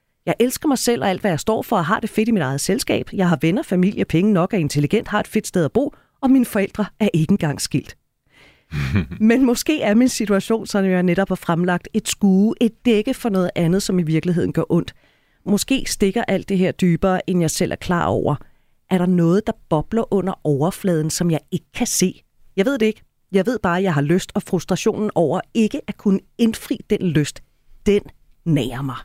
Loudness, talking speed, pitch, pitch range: -19 LUFS, 225 wpm, 195 Hz, 170-220 Hz